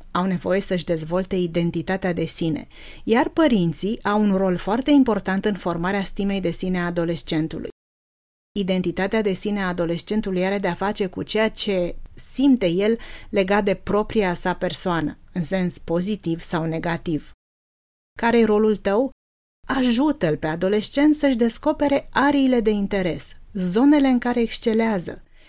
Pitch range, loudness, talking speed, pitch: 175-220 Hz, -22 LUFS, 140 wpm, 190 Hz